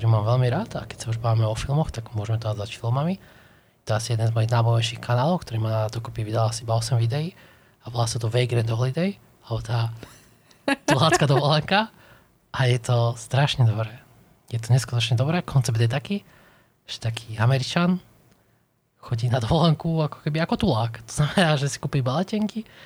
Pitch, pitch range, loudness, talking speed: 120 Hz, 115-150 Hz, -24 LUFS, 185 wpm